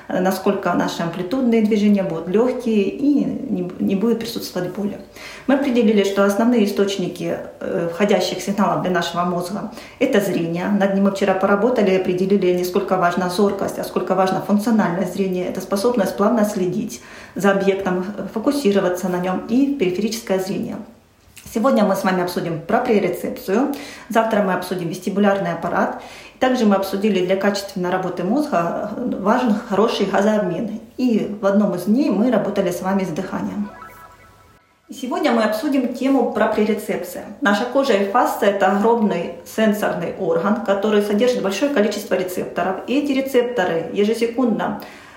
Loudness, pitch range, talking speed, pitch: -19 LUFS, 190-230 Hz, 140 wpm, 205 Hz